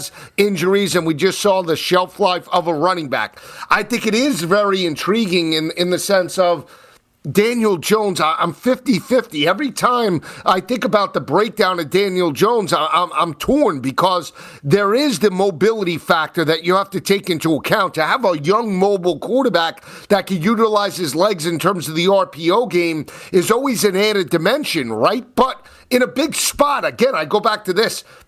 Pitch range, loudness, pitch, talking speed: 170-215 Hz, -17 LUFS, 190 Hz, 185 wpm